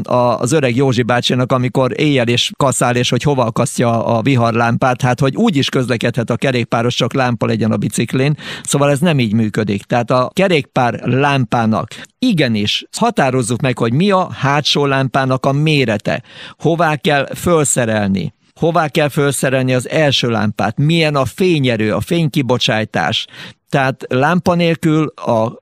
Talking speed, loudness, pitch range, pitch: 150 wpm, -15 LUFS, 120-150 Hz, 130 Hz